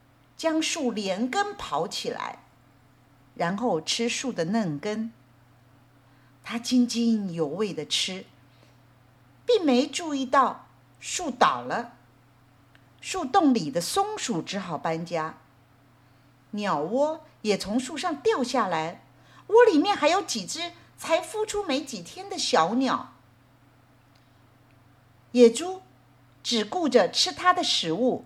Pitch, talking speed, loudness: 215 Hz, 155 characters per minute, -25 LUFS